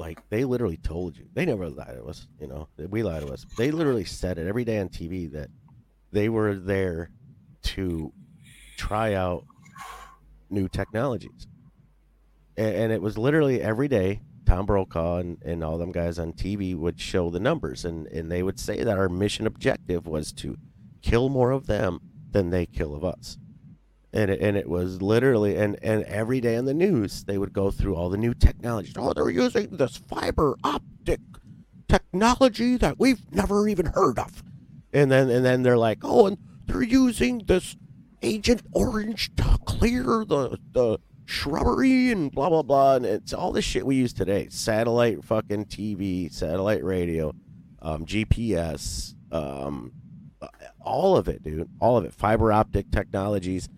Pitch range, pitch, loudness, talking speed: 85-125 Hz, 100 Hz, -25 LUFS, 170 wpm